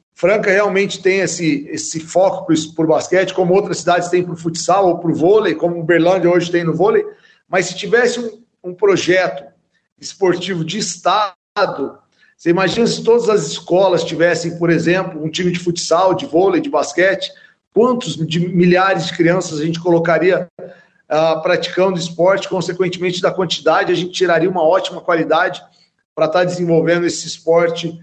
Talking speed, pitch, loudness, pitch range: 170 wpm, 180 Hz, -16 LUFS, 170-190 Hz